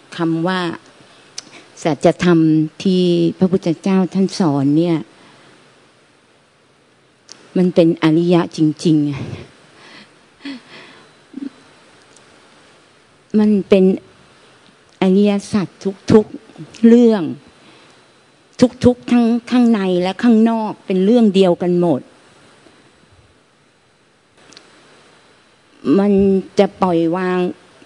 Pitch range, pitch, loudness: 170-215 Hz, 185 Hz, -15 LUFS